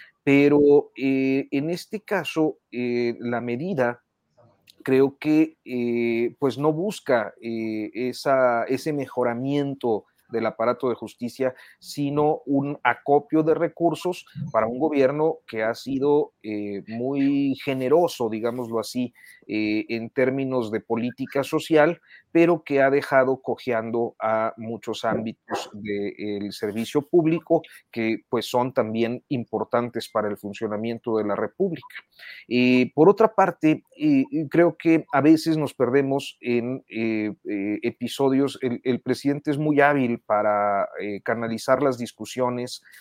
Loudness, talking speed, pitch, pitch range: -24 LUFS, 125 wpm, 130 Hz, 115-150 Hz